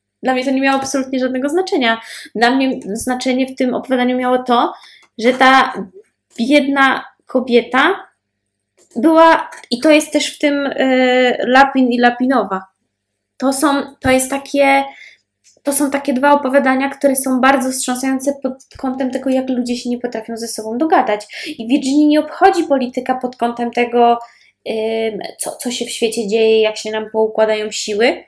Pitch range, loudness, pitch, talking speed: 240-275 Hz, -15 LUFS, 260 Hz, 160 wpm